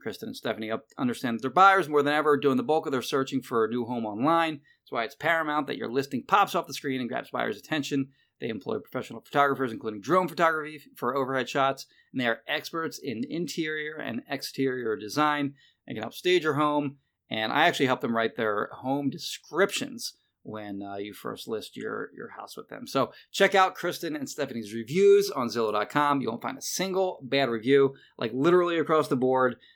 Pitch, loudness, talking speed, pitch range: 145 Hz, -27 LUFS, 205 wpm, 130-165 Hz